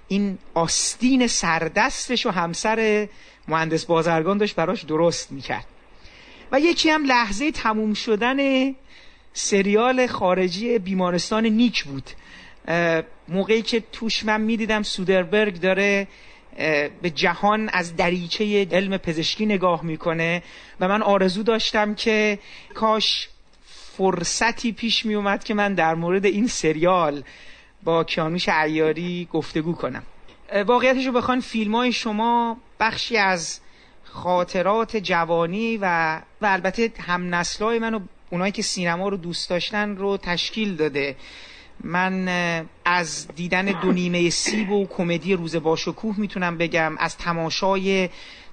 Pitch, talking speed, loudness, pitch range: 195 Hz, 120 wpm, -22 LUFS, 170-220 Hz